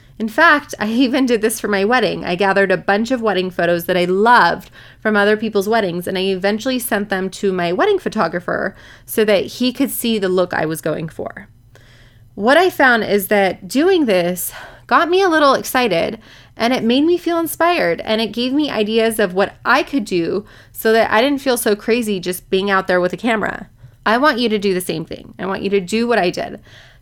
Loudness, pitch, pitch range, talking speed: -16 LUFS, 210 Hz, 185-240 Hz, 225 wpm